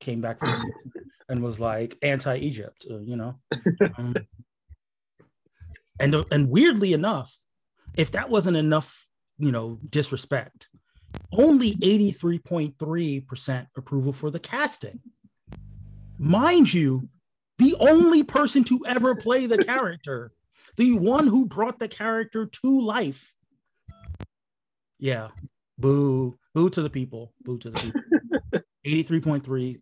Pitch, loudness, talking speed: 150 Hz, -23 LUFS, 110 wpm